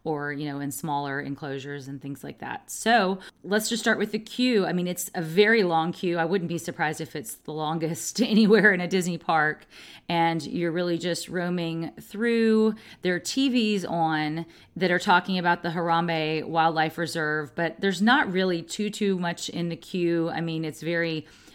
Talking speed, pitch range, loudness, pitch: 190 wpm, 160-195 Hz, -25 LUFS, 170 Hz